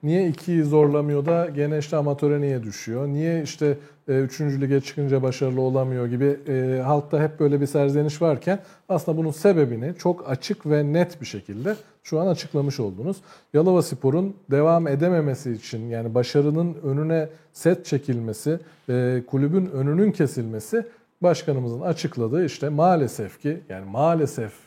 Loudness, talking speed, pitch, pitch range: -23 LUFS, 140 wpm, 150 Hz, 135-170 Hz